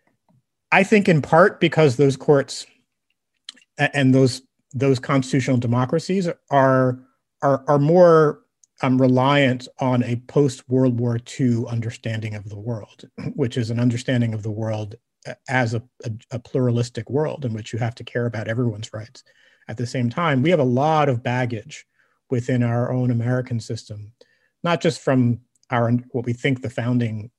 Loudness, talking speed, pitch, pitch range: -20 LUFS, 160 wpm, 125 Hz, 120-140 Hz